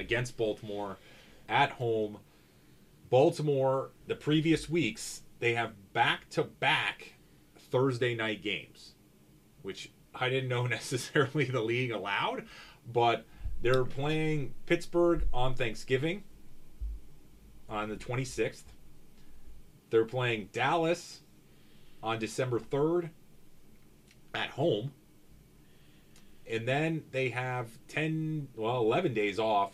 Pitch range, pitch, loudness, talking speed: 115-150 Hz, 130 Hz, -32 LUFS, 100 wpm